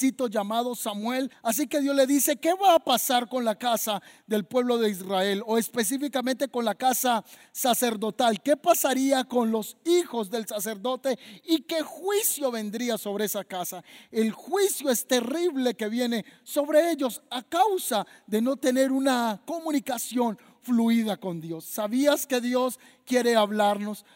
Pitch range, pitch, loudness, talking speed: 220-275 Hz, 245 Hz, -26 LUFS, 150 wpm